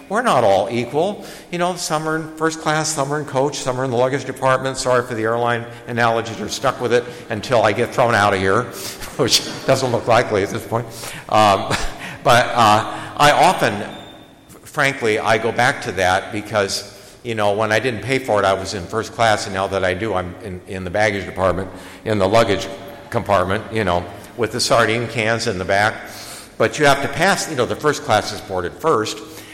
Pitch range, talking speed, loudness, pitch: 100-125 Hz, 215 wpm, -18 LUFS, 115 Hz